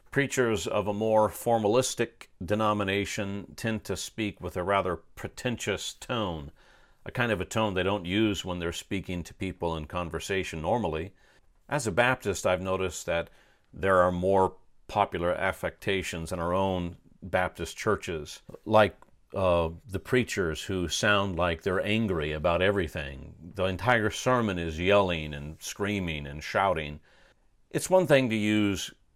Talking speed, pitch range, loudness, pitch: 145 wpm, 85-105 Hz, -28 LUFS, 95 Hz